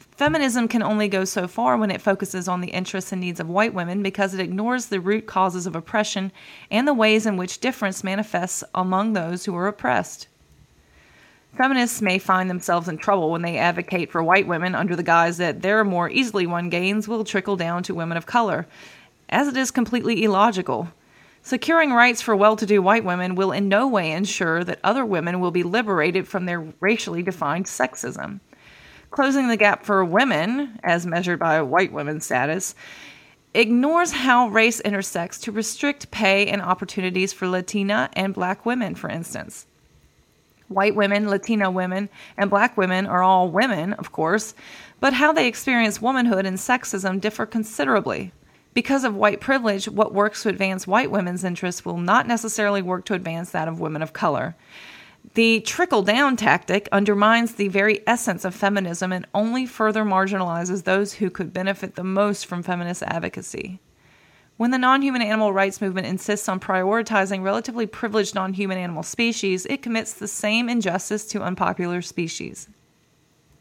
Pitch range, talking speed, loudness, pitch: 185-220 Hz, 170 wpm, -21 LUFS, 200 Hz